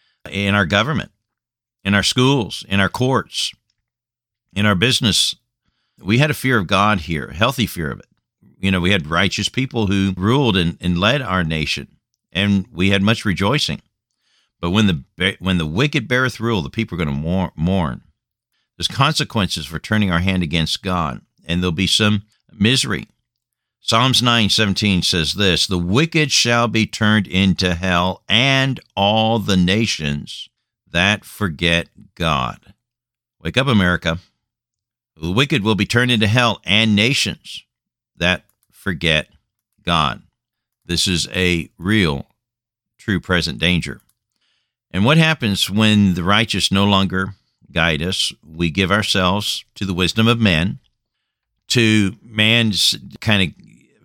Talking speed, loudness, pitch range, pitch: 145 wpm, -17 LUFS, 90-115 Hz, 100 Hz